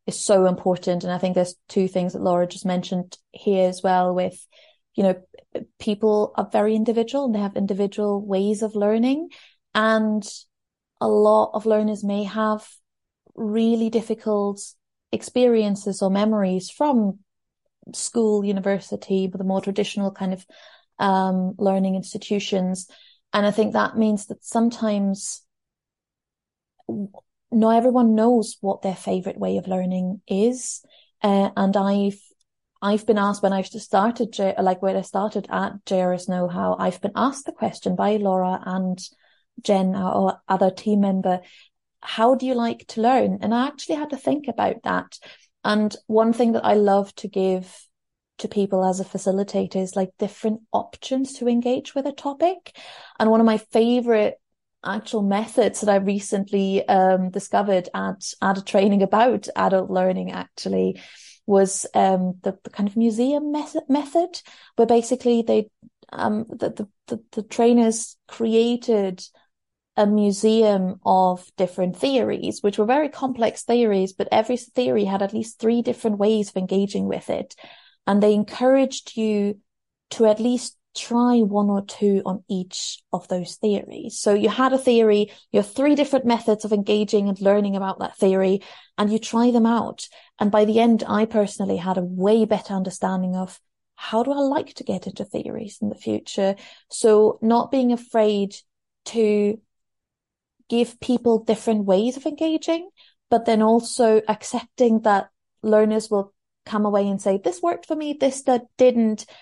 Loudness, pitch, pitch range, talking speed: -22 LUFS, 210 Hz, 195-230 Hz, 160 wpm